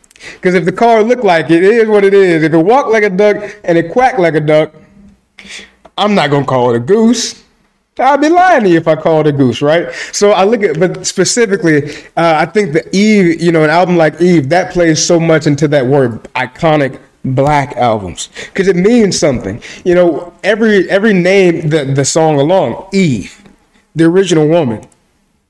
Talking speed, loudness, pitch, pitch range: 205 wpm, -10 LUFS, 175 Hz, 155-205 Hz